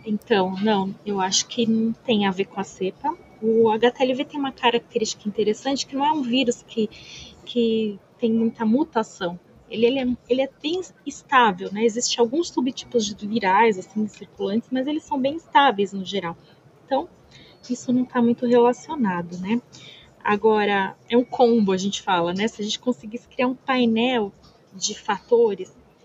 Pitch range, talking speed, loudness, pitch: 205-255 Hz, 170 wpm, -22 LUFS, 230 Hz